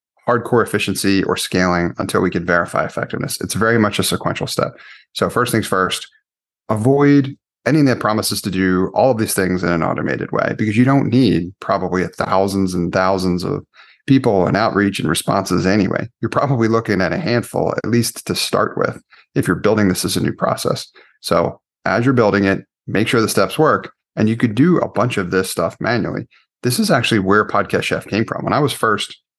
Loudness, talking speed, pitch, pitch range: -17 LUFS, 205 wpm, 105 Hz, 95-120 Hz